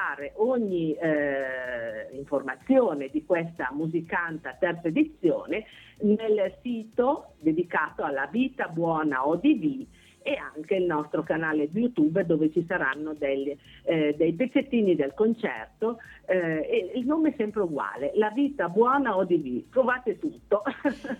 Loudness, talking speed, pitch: -27 LUFS, 125 wpm, 195 Hz